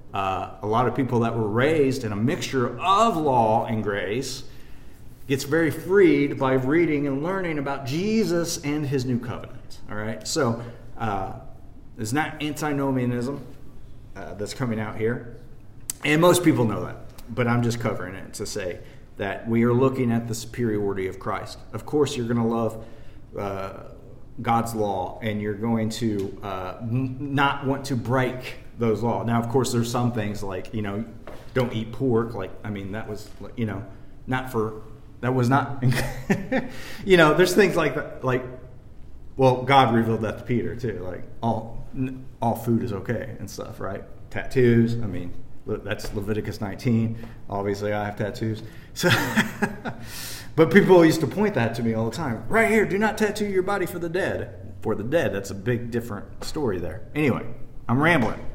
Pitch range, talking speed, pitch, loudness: 110-135 Hz, 175 wpm, 115 Hz, -24 LUFS